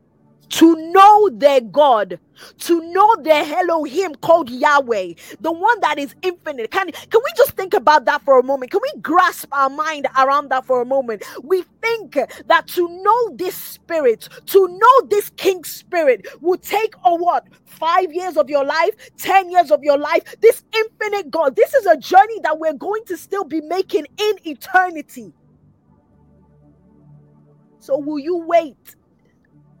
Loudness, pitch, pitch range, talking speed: -16 LUFS, 335 Hz, 285-390 Hz, 165 wpm